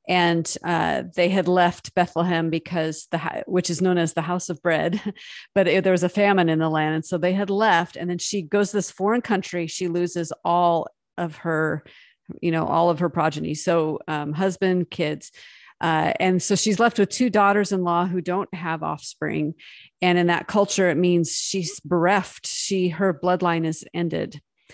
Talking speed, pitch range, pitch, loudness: 195 wpm, 165-190 Hz, 175 Hz, -22 LUFS